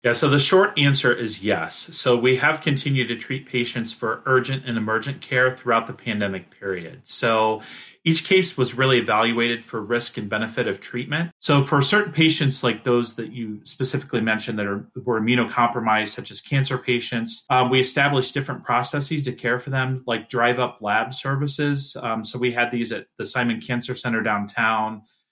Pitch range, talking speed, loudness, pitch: 115-135 Hz, 185 wpm, -22 LUFS, 125 Hz